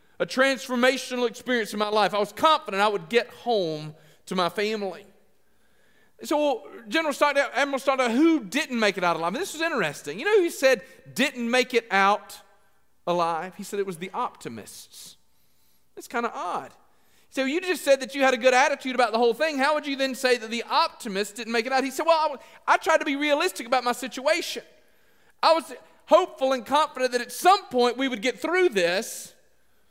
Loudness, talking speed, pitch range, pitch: -24 LUFS, 210 wpm, 210-295 Hz, 255 Hz